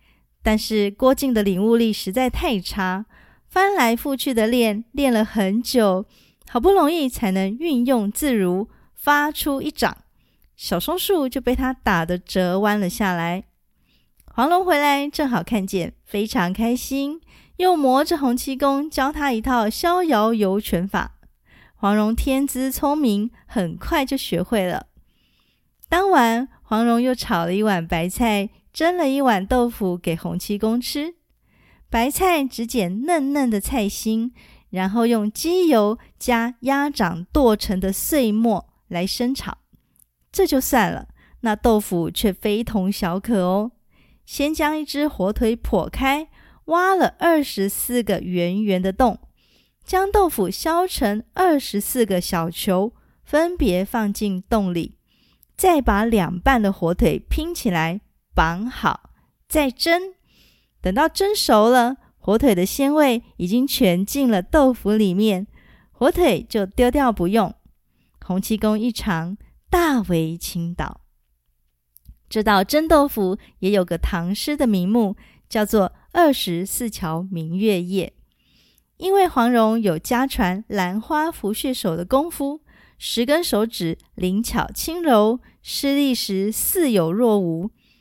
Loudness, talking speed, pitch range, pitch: -20 LUFS, 195 characters per minute, 195-275 Hz, 230 Hz